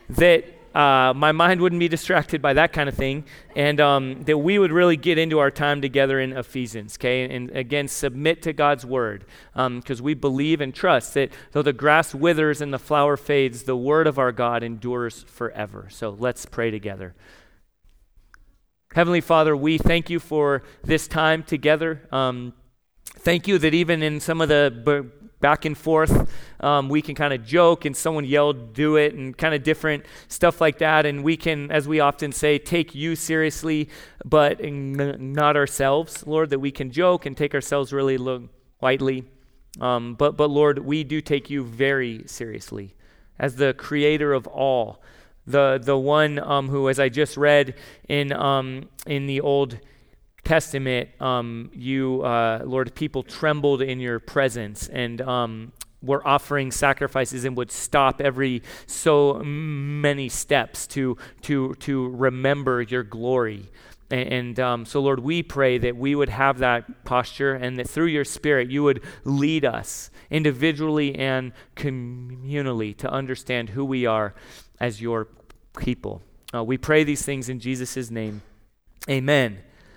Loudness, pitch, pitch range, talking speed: -22 LUFS, 140 Hz, 125-150 Hz, 165 wpm